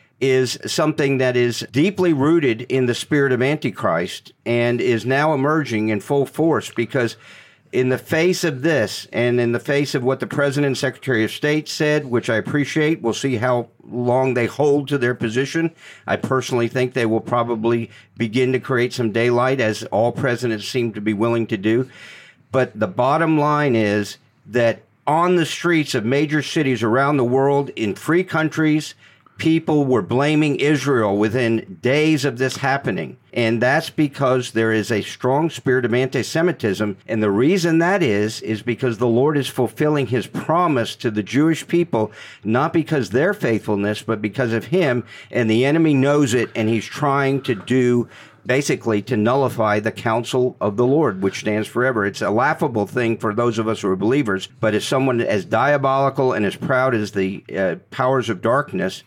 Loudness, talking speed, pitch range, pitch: -19 LUFS, 180 wpm, 115-145 Hz, 125 Hz